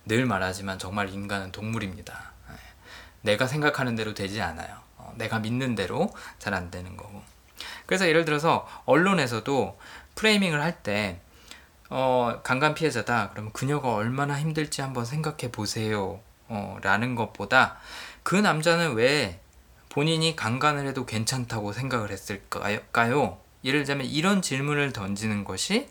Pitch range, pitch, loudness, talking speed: 100-145 Hz, 115 Hz, -26 LUFS, 300 characters per minute